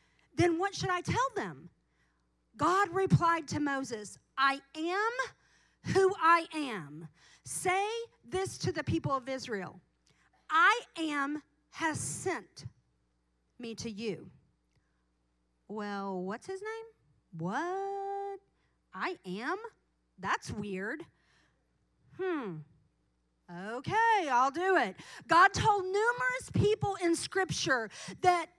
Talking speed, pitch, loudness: 105 wpm, 320 Hz, -32 LUFS